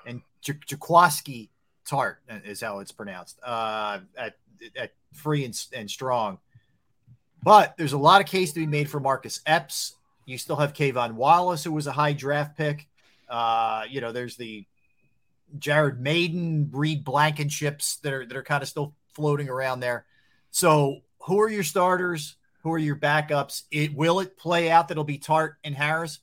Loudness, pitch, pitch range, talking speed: -24 LUFS, 145 Hz, 130-160 Hz, 175 wpm